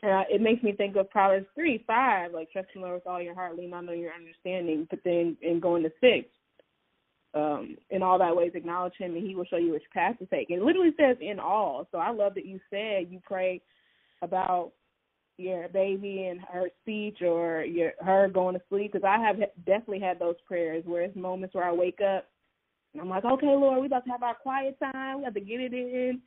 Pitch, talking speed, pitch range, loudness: 185 Hz, 235 wpm, 175-210 Hz, -28 LUFS